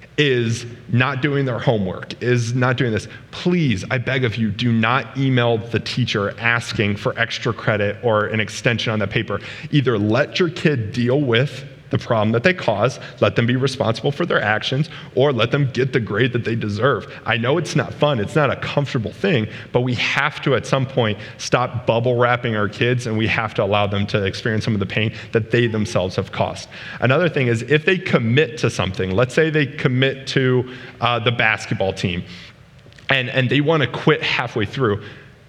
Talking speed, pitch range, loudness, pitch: 205 wpm, 110-135 Hz, -19 LUFS, 125 Hz